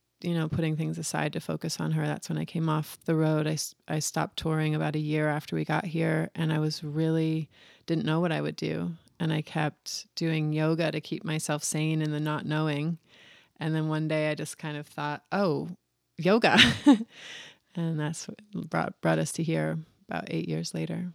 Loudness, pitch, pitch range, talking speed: -29 LUFS, 155 Hz, 145-160 Hz, 205 wpm